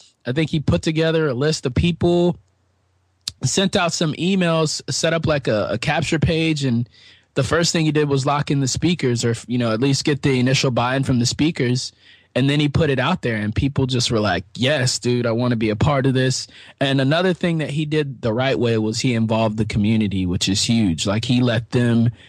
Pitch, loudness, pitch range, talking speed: 130 Hz, -19 LUFS, 115-155 Hz, 235 wpm